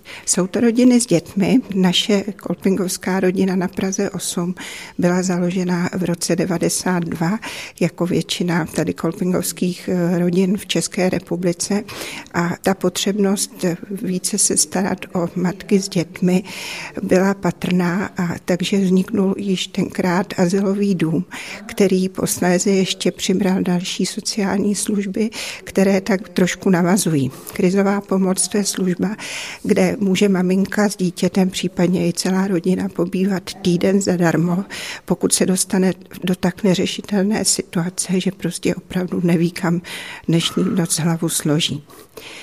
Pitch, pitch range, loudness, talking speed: 185 Hz, 180-195 Hz, -19 LUFS, 125 wpm